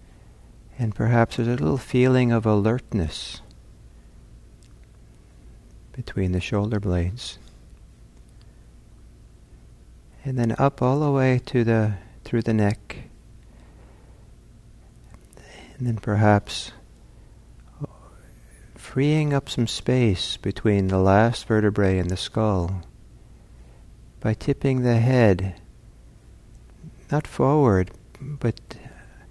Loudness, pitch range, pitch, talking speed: -23 LUFS, 95-120 Hz, 110 Hz, 90 wpm